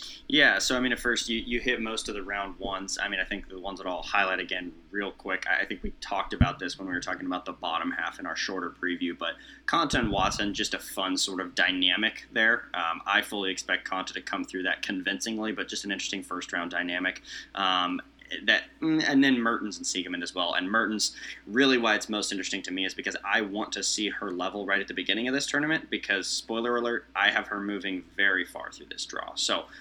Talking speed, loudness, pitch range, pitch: 240 wpm, -28 LUFS, 95-115 Hz, 100 Hz